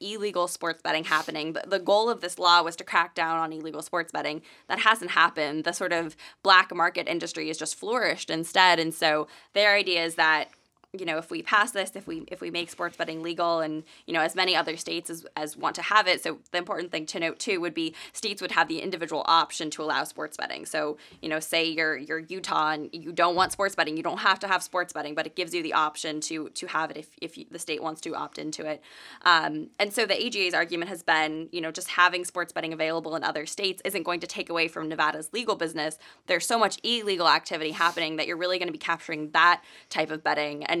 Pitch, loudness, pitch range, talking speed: 170 Hz, -26 LUFS, 160-180 Hz, 245 wpm